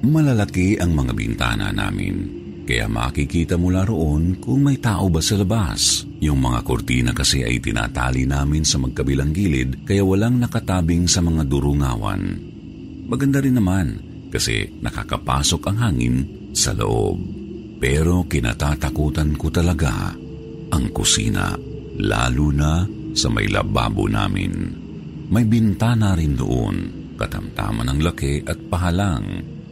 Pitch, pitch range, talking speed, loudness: 90 Hz, 75-105 Hz, 125 wpm, -20 LUFS